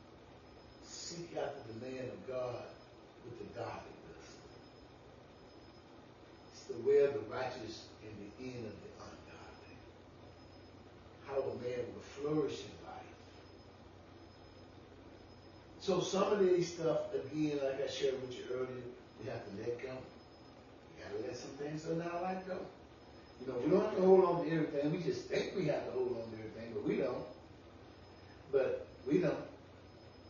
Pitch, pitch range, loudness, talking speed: 130 Hz, 110-170 Hz, -37 LUFS, 160 wpm